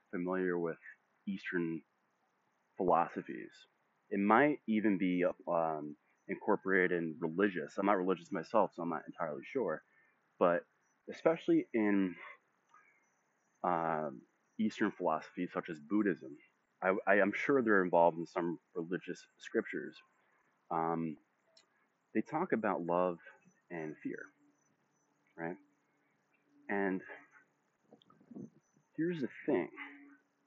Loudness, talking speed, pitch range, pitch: -35 LUFS, 100 wpm, 85-110 Hz, 95 Hz